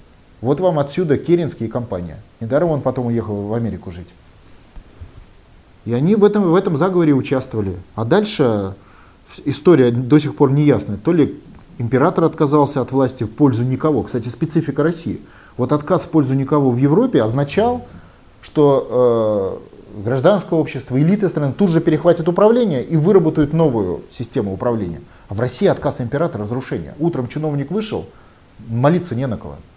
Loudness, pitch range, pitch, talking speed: -17 LUFS, 110-160 Hz, 135 Hz, 155 wpm